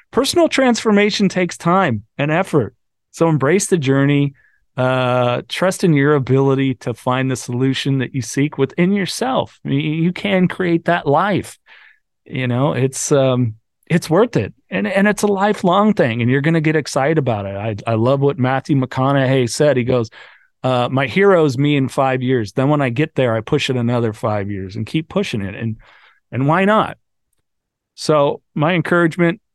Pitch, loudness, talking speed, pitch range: 140 Hz, -17 LUFS, 185 wpm, 125-175 Hz